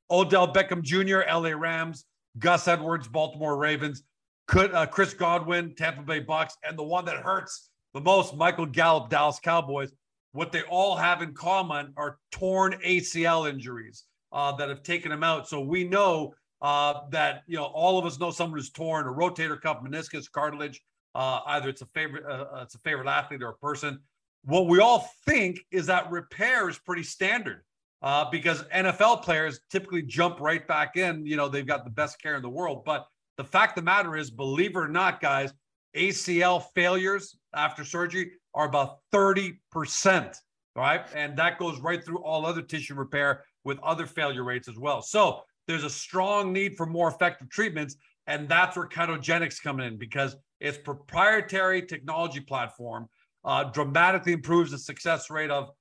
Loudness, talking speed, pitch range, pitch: -27 LUFS, 175 wpm, 145-175 Hz, 160 Hz